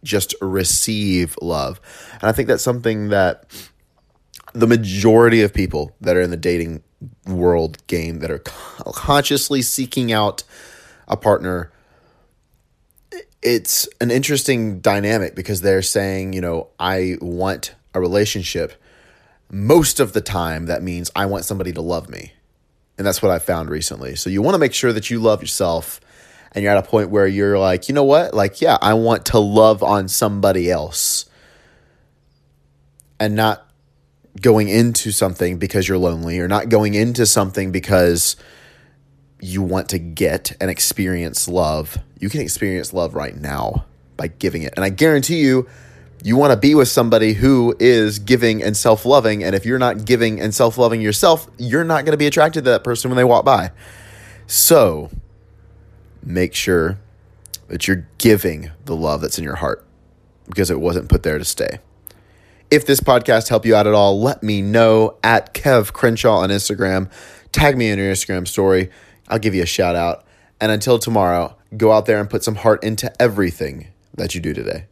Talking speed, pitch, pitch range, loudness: 175 wpm, 100 Hz, 90-115 Hz, -17 LUFS